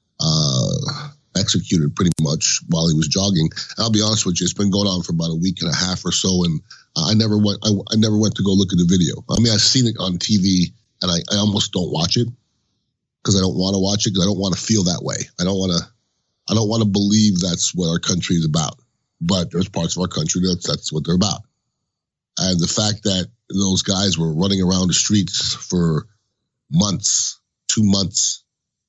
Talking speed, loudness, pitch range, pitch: 230 wpm, -18 LUFS, 90-110 Hz, 95 Hz